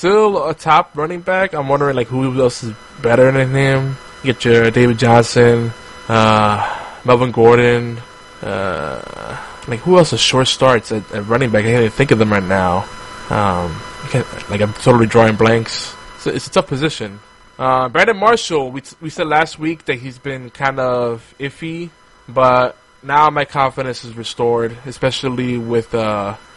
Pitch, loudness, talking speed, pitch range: 125 Hz, -15 LUFS, 170 wpm, 115-140 Hz